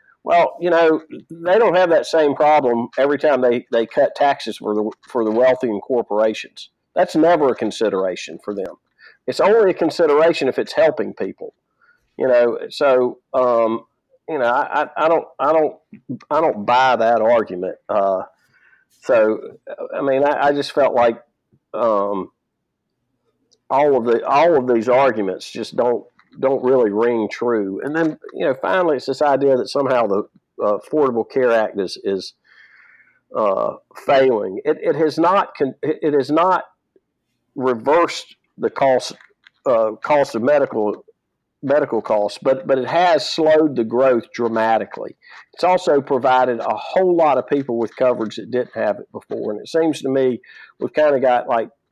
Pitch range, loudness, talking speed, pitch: 115-155 Hz, -18 LUFS, 165 wpm, 130 Hz